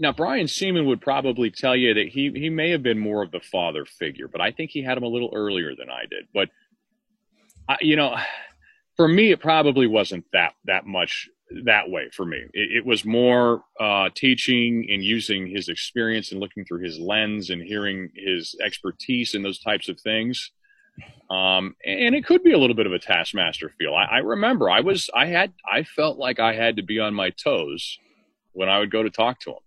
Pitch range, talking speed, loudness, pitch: 105-155 Hz, 215 wpm, -22 LUFS, 120 Hz